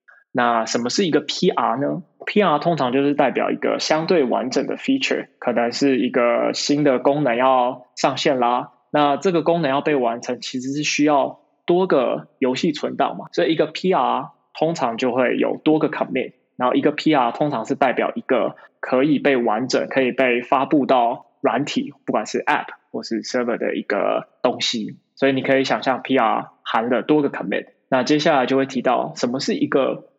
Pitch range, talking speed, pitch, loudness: 125-150 Hz, 320 characters per minute, 140 Hz, -20 LUFS